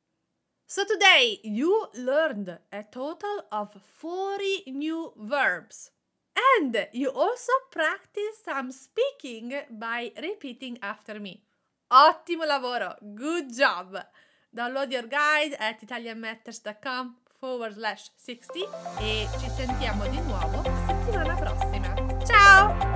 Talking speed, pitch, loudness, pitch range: 105 wpm, 250 Hz, -25 LUFS, 205-315 Hz